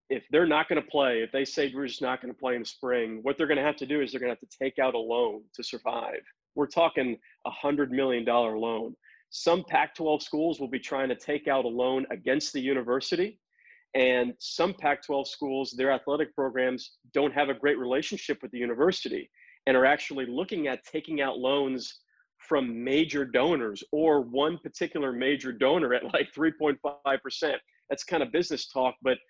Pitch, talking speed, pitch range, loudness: 135 Hz, 205 wpm, 130-150 Hz, -28 LUFS